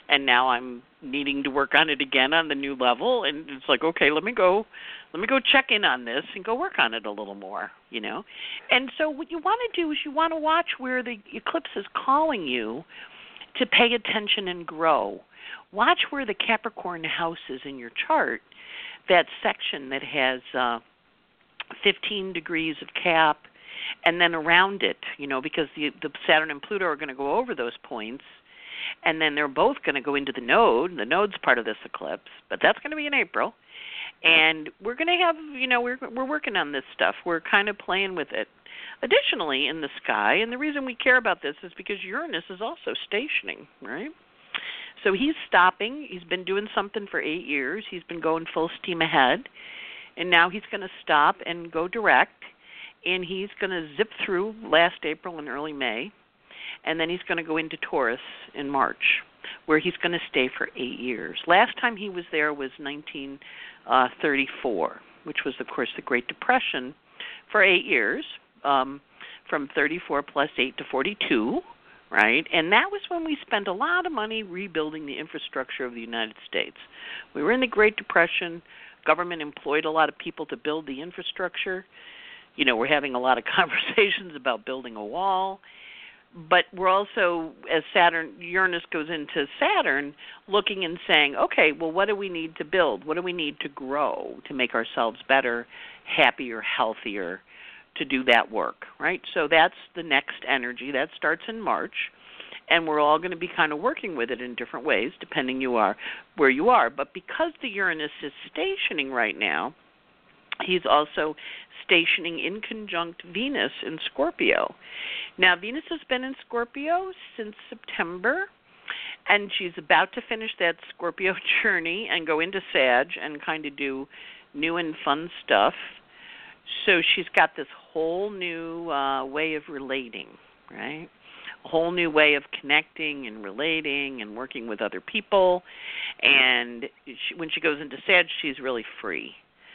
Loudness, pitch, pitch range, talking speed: -24 LUFS, 170 Hz, 145-215 Hz, 185 wpm